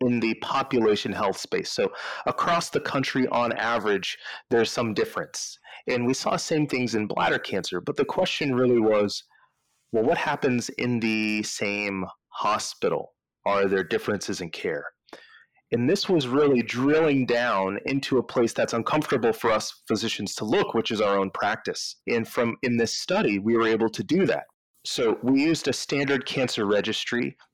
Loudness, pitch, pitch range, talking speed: -25 LUFS, 120 Hz, 105-135 Hz, 170 wpm